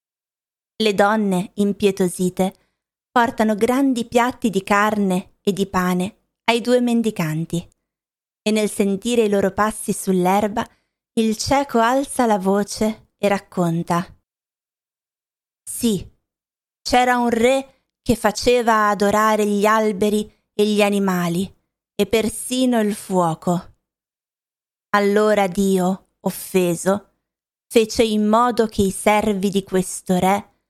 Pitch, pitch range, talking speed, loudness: 210 Hz, 195-230 Hz, 110 wpm, -19 LUFS